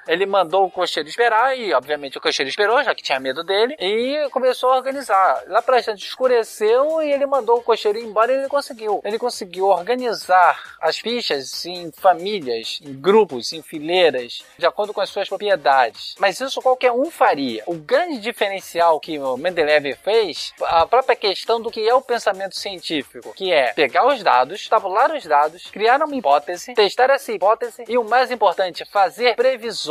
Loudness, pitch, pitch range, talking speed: -19 LUFS, 215 Hz, 180-250 Hz, 180 wpm